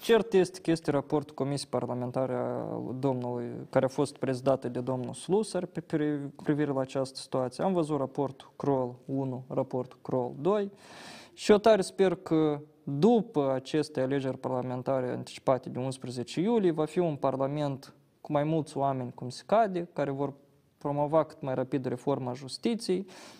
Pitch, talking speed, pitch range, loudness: 140 Hz, 155 wpm, 130-160 Hz, -30 LUFS